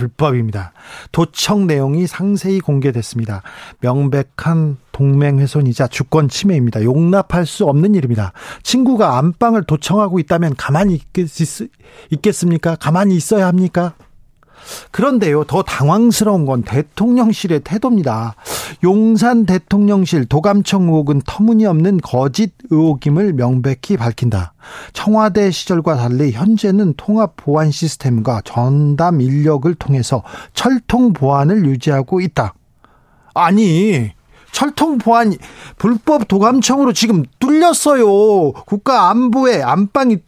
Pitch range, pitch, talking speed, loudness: 140-210 Hz, 170 Hz, 280 characters per minute, -14 LUFS